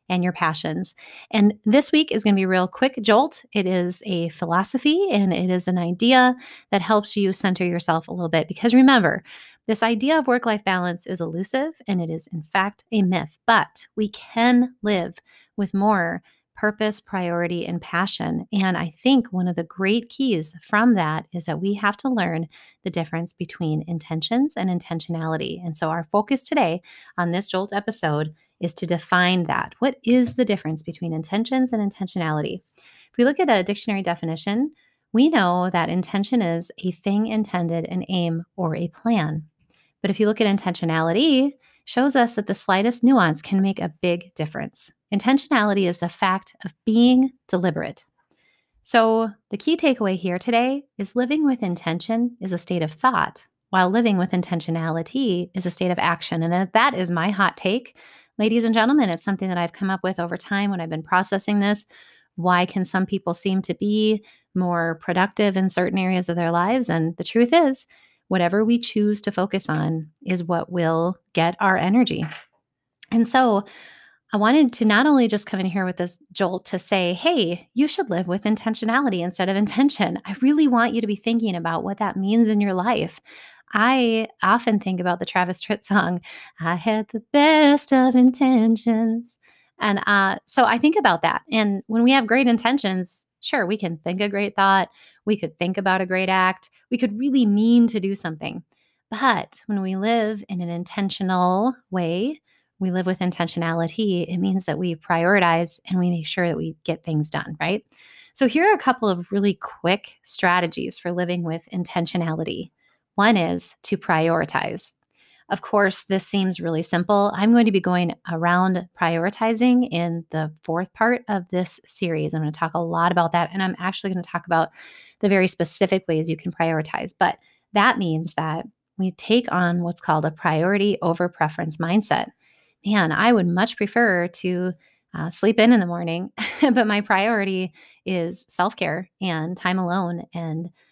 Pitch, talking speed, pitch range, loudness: 190 Hz, 185 wpm, 175-225 Hz, -21 LUFS